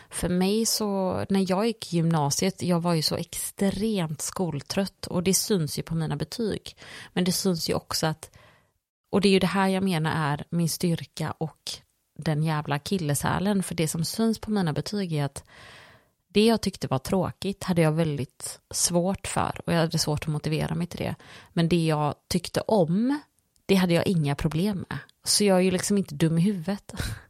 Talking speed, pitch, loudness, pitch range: 200 wpm, 175 Hz, -26 LUFS, 155-195 Hz